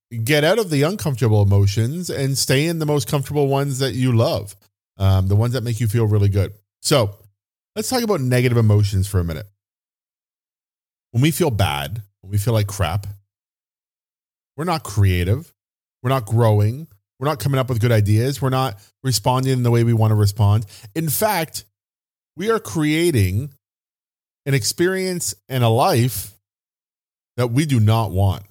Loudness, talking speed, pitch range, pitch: -19 LUFS, 170 wpm, 100-140 Hz, 115 Hz